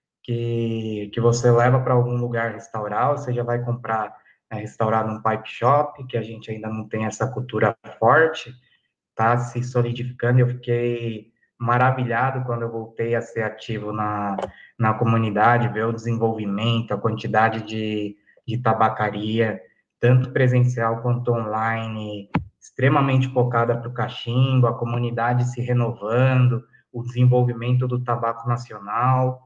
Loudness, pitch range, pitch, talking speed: -22 LUFS, 110-125 Hz, 120 Hz, 135 wpm